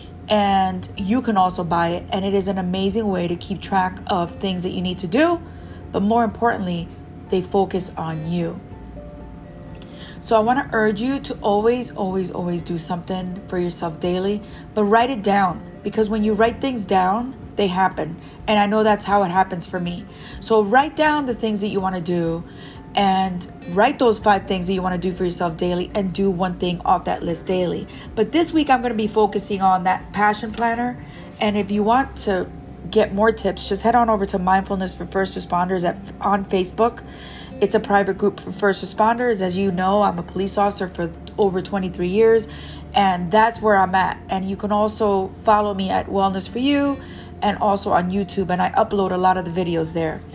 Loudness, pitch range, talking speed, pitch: -20 LUFS, 185-215 Hz, 205 wpm, 195 Hz